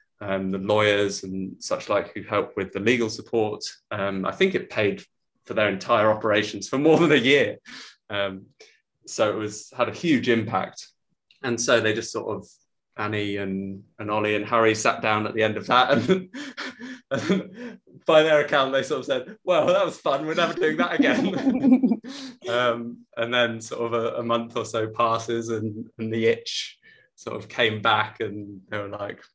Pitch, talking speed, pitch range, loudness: 115 Hz, 190 wpm, 105-150 Hz, -24 LUFS